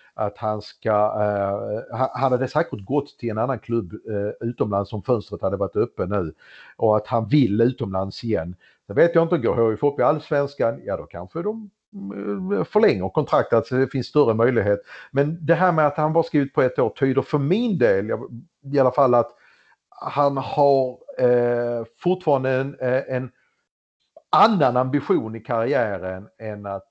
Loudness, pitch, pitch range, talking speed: -22 LUFS, 125 Hz, 110-145 Hz, 175 wpm